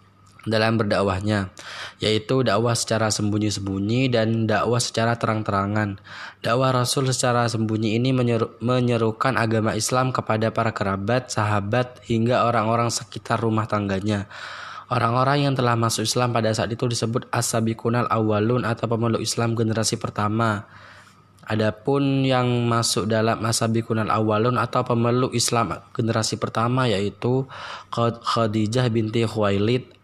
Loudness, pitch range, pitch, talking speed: -22 LUFS, 110-120 Hz, 115 Hz, 120 wpm